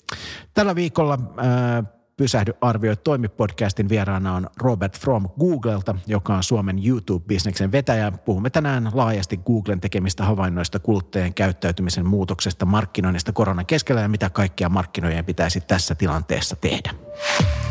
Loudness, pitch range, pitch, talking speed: -22 LUFS, 95-120 Hz, 105 Hz, 120 wpm